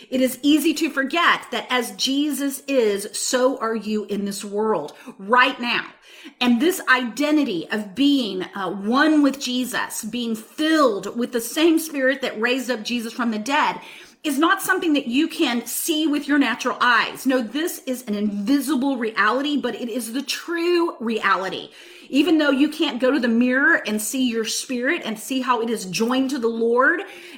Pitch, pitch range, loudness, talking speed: 255 Hz, 230-295 Hz, -21 LUFS, 180 wpm